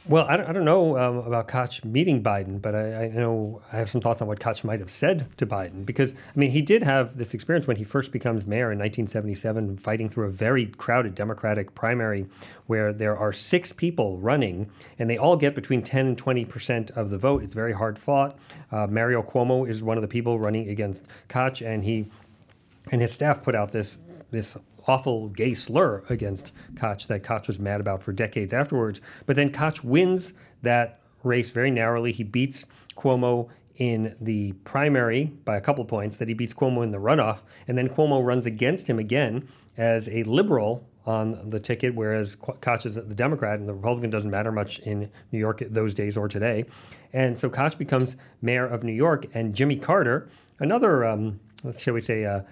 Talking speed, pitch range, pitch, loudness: 205 wpm, 110-130 Hz, 115 Hz, -25 LUFS